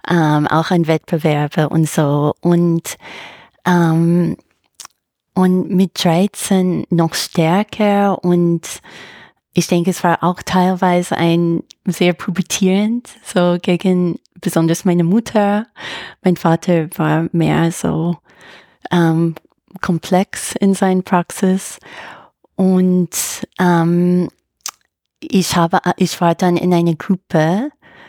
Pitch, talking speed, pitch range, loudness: 175 Hz, 105 wpm, 165-185 Hz, -16 LUFS